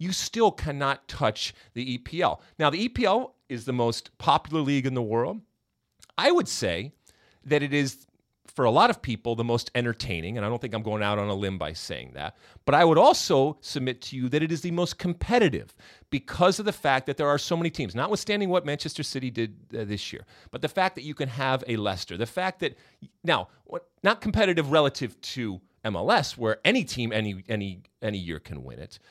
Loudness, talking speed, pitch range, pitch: -26 LUFS, 210 wpm, 110-150 Hz, 125 Hz